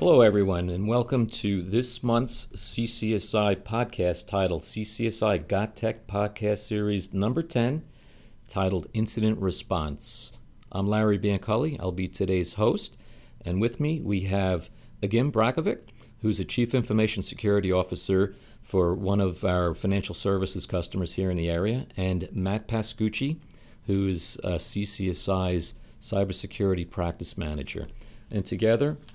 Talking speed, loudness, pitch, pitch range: 130 wpm, -27 LUFS, 100 Hz, 95-115 Hz